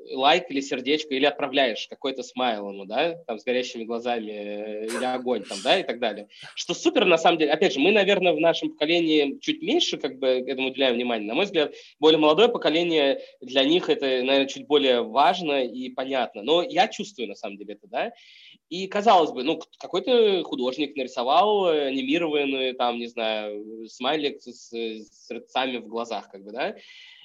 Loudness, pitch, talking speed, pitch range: -24 LUFS, 135 Hz, 180 wpm, 120-165 Hz